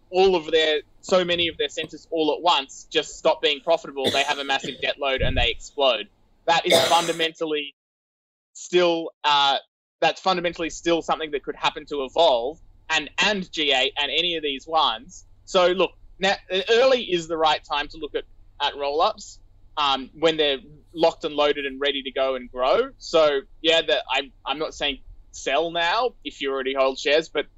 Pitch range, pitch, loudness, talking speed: 140-170 Hz, 155 Hz, -22 LUFS, 185 wpm